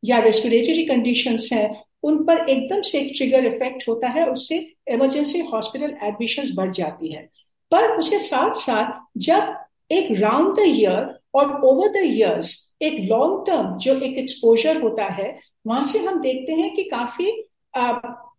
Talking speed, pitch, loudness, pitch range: 150 wpm, 260 Hz, -20 LUFS, 230-325 Hz